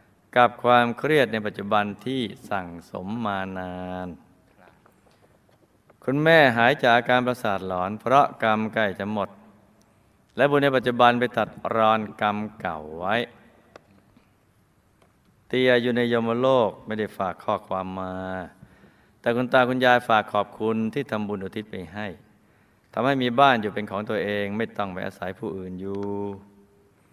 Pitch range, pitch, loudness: 100-120 Hz, 105 Hz, -23 LUFS